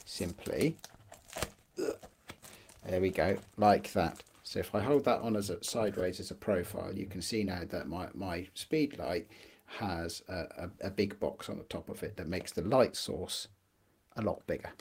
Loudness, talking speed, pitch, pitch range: -35 LUFS, 185 wpm, 95 Hz, 90-105 Hz